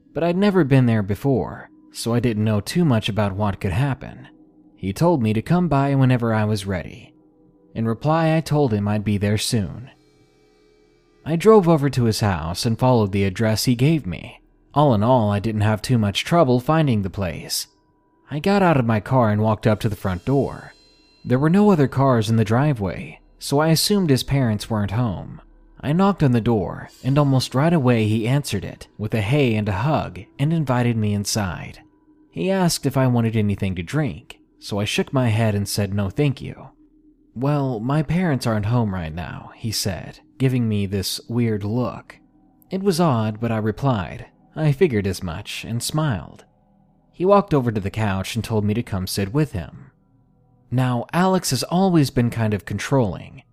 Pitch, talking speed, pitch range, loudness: 120 Hz, 195 wpm, 105-145 Hz, -20 LUFS